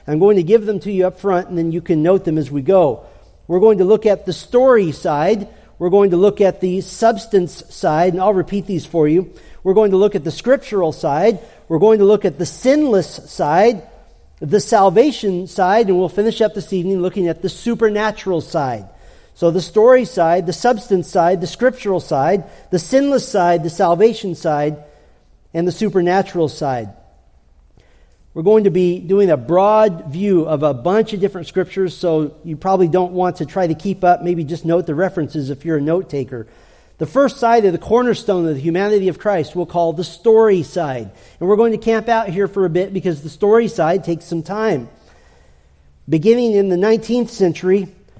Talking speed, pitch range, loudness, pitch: 200 wpm, 165-205 Hz, -16 LUFS, 185 Hz